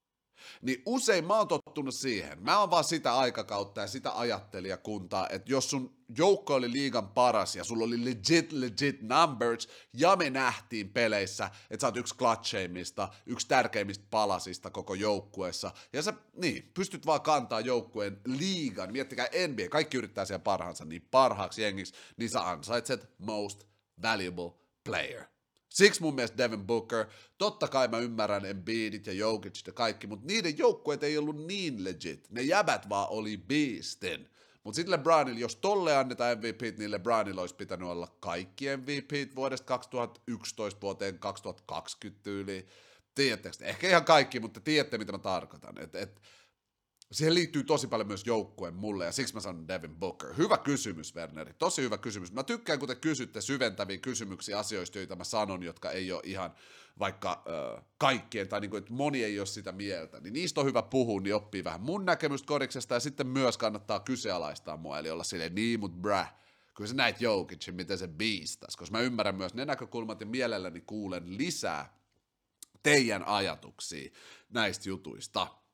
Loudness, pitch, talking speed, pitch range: -32 LUFS, 115 Hz, 165 wpm, 100-140 Hz